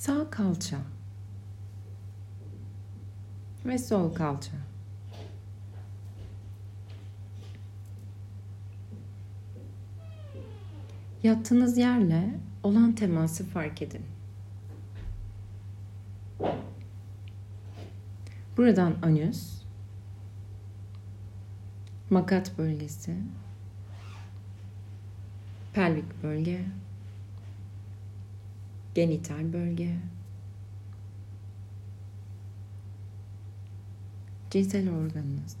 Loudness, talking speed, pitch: -29 LUFS, 35 wpm, 100 Hz